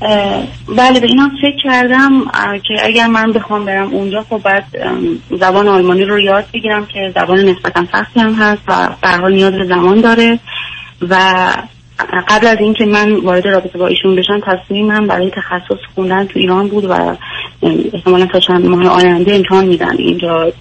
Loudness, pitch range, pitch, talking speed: -11 LUFS, 185-215 Hz, 195 Hz, 170 wpm